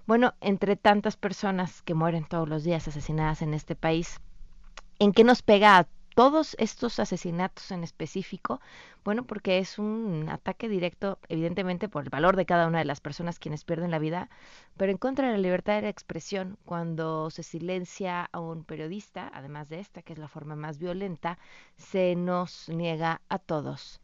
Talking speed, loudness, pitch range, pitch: 180 wpm, -28 LUFS, 165-200 Hz, 180 Hz